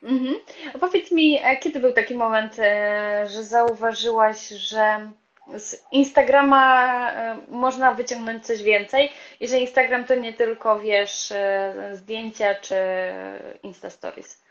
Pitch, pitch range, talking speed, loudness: 230 Hz, 210-260 Hz, 110 wpm, -21 LUFS